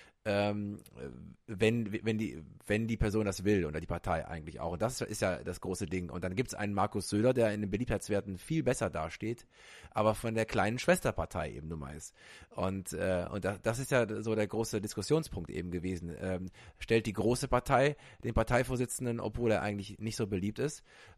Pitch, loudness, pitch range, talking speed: 105 Hz, -34 LUFS, 95-115 Hz, 195 wpm